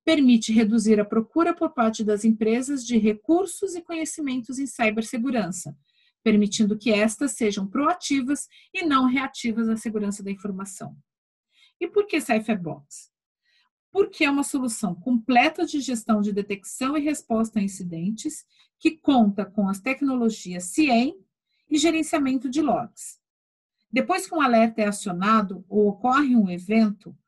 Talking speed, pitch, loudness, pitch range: 140 wpm, 230 Hz, -23 LUFS, 210-290 Hz